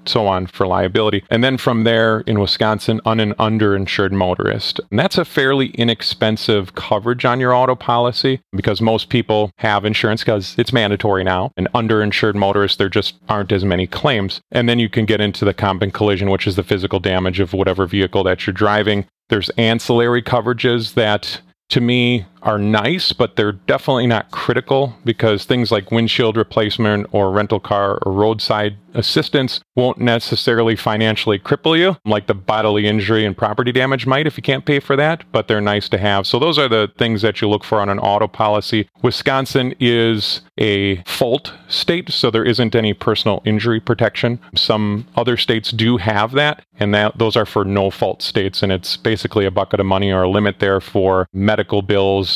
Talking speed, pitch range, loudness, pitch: 190 wpm, 100-120 Hz, -16 LUFS, 110 Hz